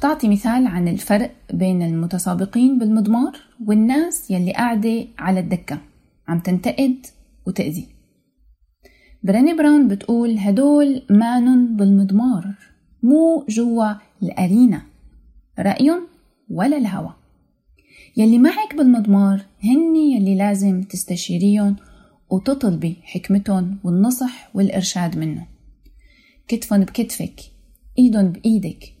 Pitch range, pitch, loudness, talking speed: 185-245 Hz, 205 Hz, -18 LUFS, 90 wpm